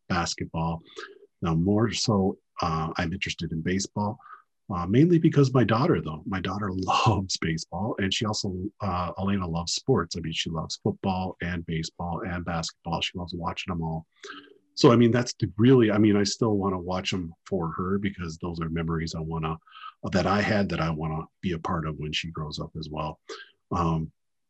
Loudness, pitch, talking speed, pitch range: -27 LUFS, 90 Hz, 200 wpm, 80-105 Hz